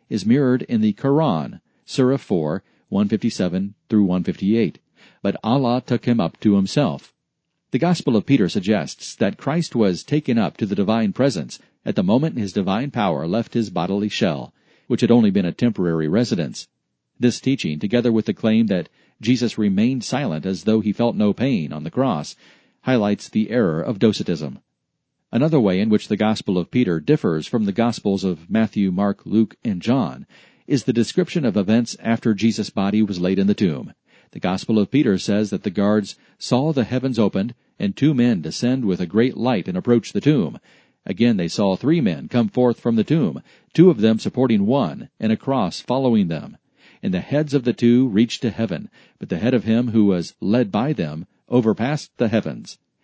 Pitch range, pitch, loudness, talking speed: 105-130 Hz, 115 Hz, -20 LUFS, 190 wpm